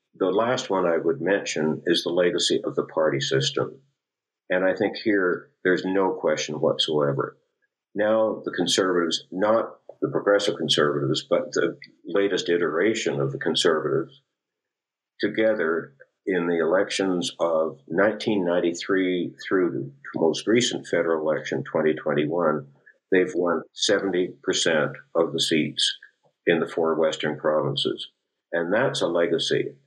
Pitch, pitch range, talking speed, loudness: 90 Hz, 80-105 Hz, 125 wpm, -24 LUFS